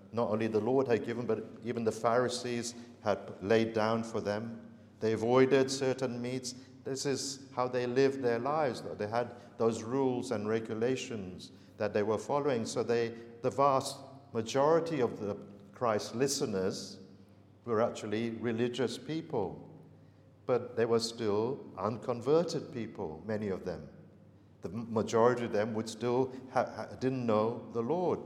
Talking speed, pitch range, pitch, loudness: 150 wpm, 110-130 Hz, 120 Hz, -33 LUFS